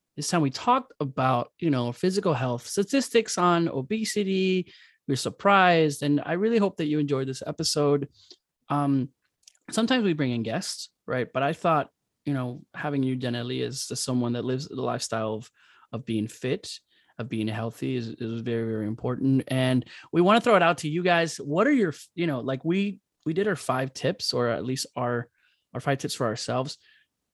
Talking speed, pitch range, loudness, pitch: 195 wpm, 125-175 Hz, -26 LUFS, 140 Hz